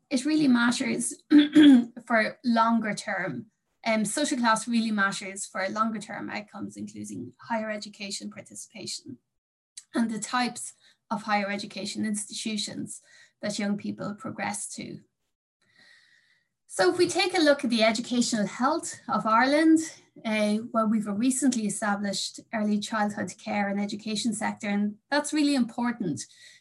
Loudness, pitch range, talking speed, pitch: -26 LUFS, 205-260 Hz, 130 wpm, 220 Hz